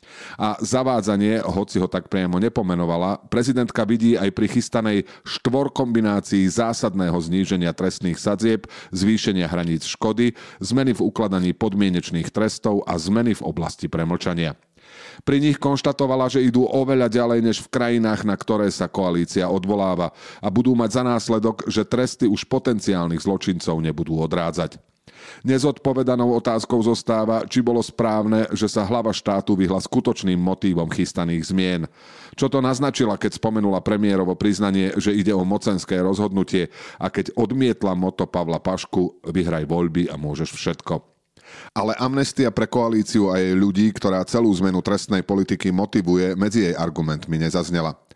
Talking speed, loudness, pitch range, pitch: 140 wpm, -21 LUFS, 90-115 Hz, 105 Hz